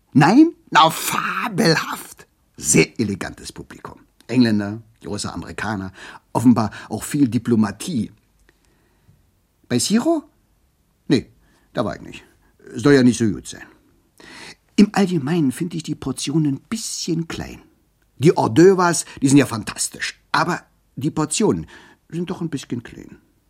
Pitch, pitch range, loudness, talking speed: 140 Hz, 115-170 Hz, -19 LUFS, 130 wpm